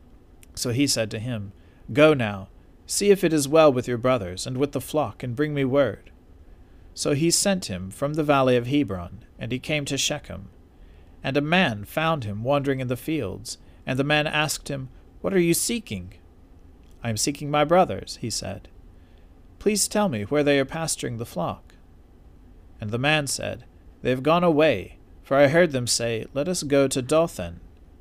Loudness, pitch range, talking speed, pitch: -23 LUFS, 90-150 Hz, 190 wpm, 125 Hz